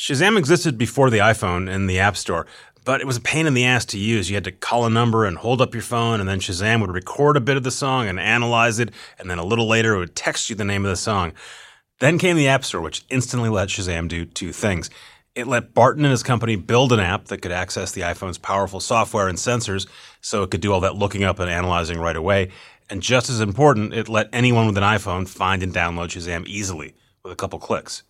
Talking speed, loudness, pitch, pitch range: 250 wpm, -20 LUFS, 105 Hz, 95-120 Hz